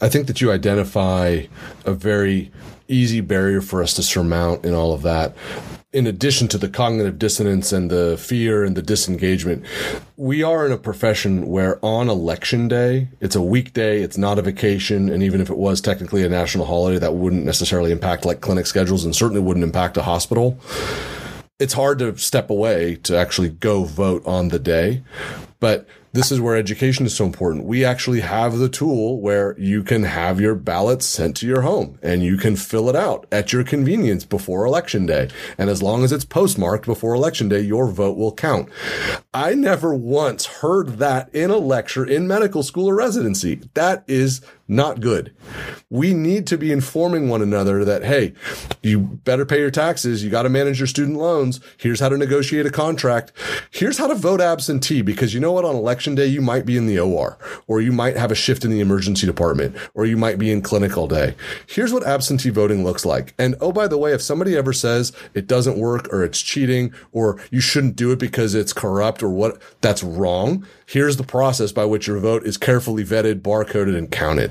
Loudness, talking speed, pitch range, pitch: -19 LUFS, 205 wpm, 95-130 Hz, 110 Hz